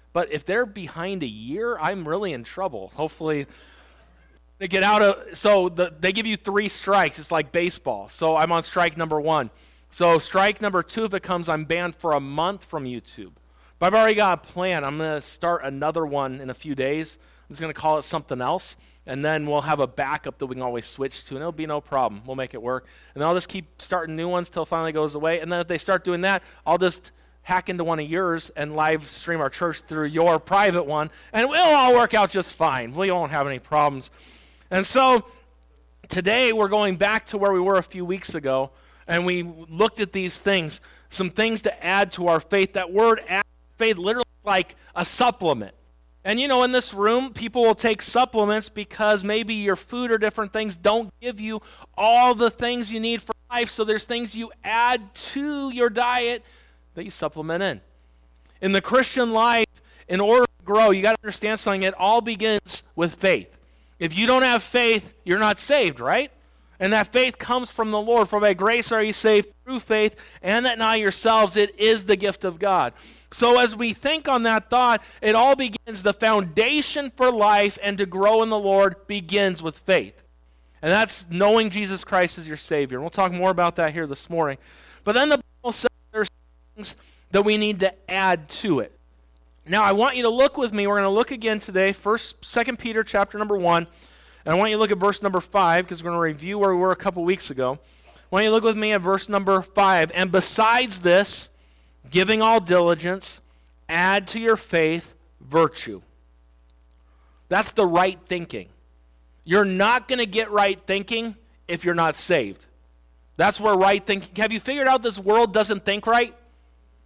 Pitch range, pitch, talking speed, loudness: 155-220 Hz, 190 Hz, 205 wpm, -22 LUFS